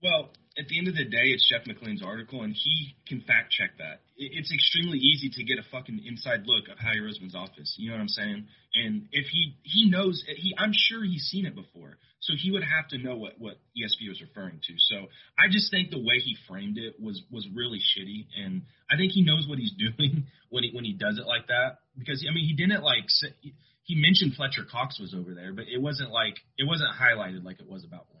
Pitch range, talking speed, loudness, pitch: 120-185 Hz, 245 wpm, -26 LUFS, 145 Hz